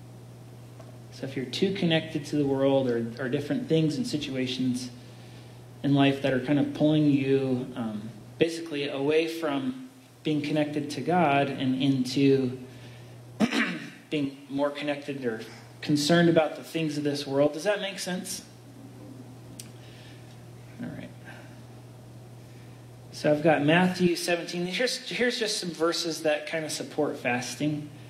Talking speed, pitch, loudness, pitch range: 135 wpm, 135 Hz, -27 LUFS, 125-155 Hz